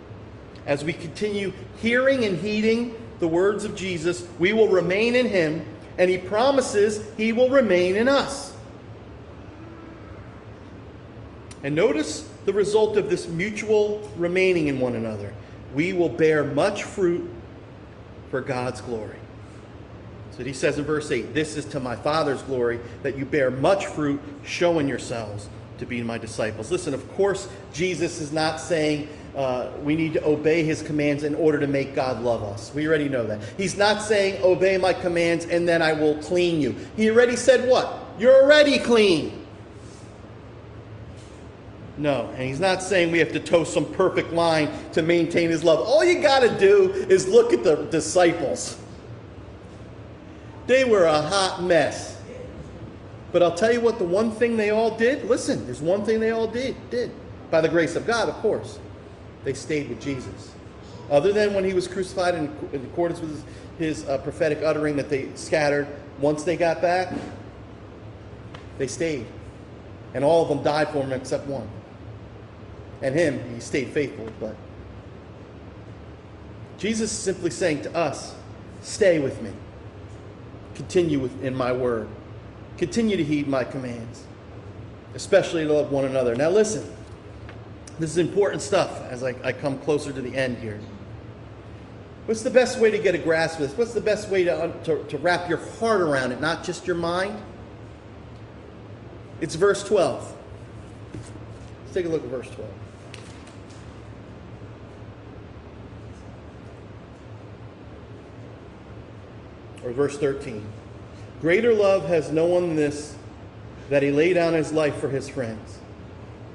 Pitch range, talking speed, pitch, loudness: 105-175 Hz, 155 wpm, 140 Hz, -23 LUFS